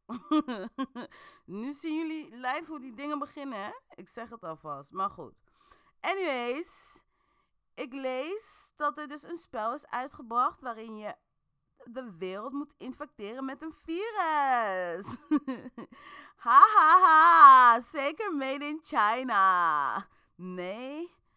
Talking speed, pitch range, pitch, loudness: 120 wpm, 240-320 Hz, 280 Hz, -25 LUFS